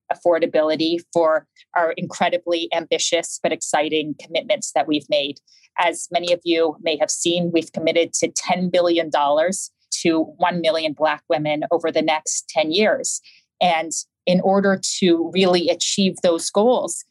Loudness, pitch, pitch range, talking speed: -20 LUFS, 170 Hz, 160-180 Hz, 145 wpm